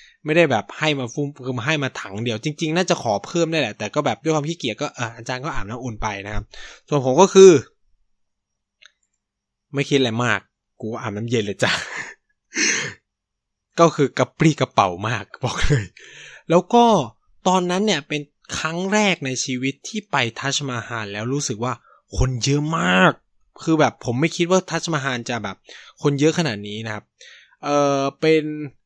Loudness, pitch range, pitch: -20 LUFS, 125-165 Hz, 140 Hz